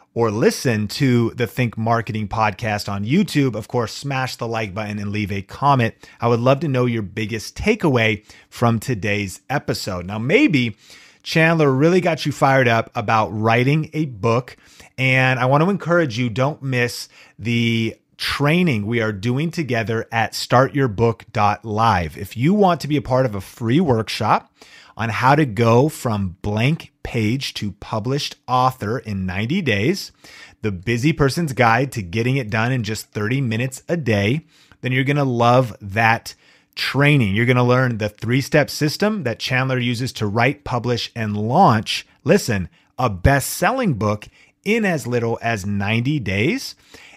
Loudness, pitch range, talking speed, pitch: -19 LUFS, 110-140 Hz, 165 wpm, 120 Hz